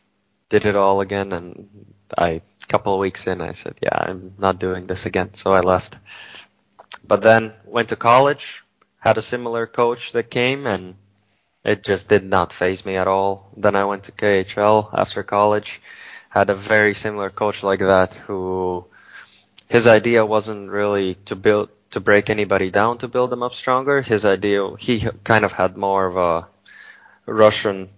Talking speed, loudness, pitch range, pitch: 175 wpm, -19 LUFS, 95-110 Hz, 100 Hz